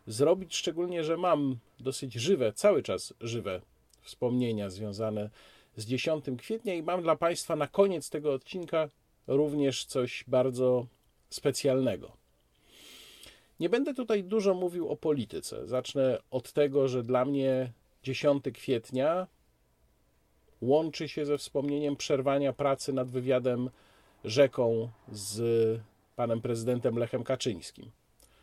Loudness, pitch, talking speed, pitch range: -30 LUFS, 130 Hz, 115 wpm, 115-150 Hz